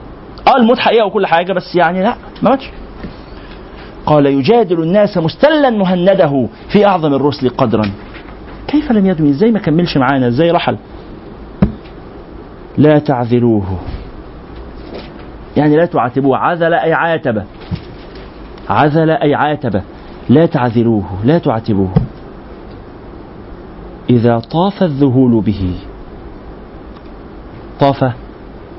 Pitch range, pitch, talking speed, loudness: 115-175 Hz, 145 Hz, 100 wpm, -12 LUFS